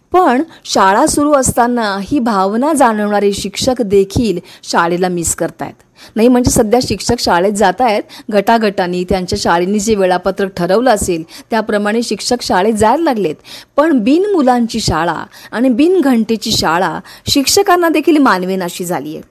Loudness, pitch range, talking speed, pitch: -13 LUFS, 195-270 Hz, 135 wpm, 225 Hz